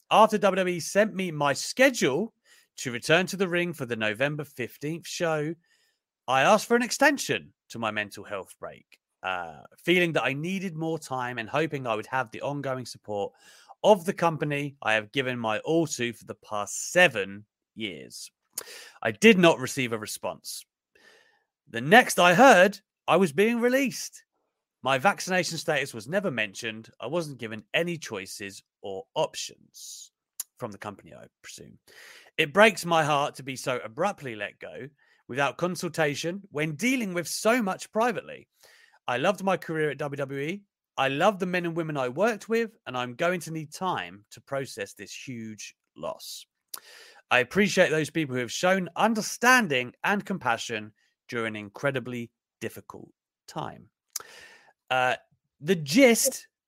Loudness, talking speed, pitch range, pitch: -26 LUFS, 160 wpm, 125-200 Hz, 160 Hz